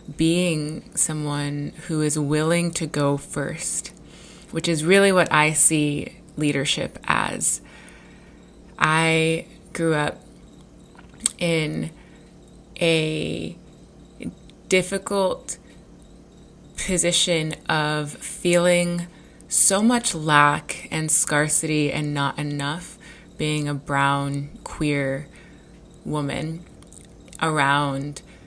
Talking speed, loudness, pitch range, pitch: 80 wpm, -22 LUFS, 145-170 Hz, 155 Hz